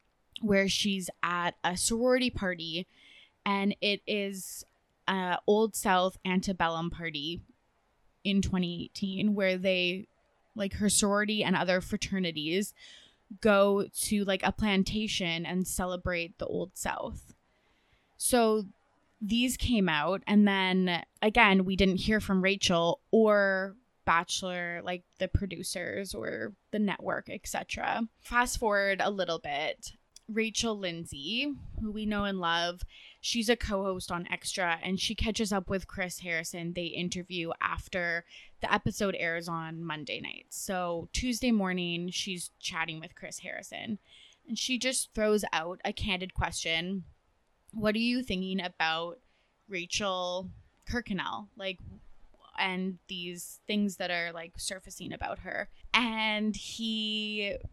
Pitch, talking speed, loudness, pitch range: 190 Hz, 130 wpm, -31 LUFS, 175-210 Hz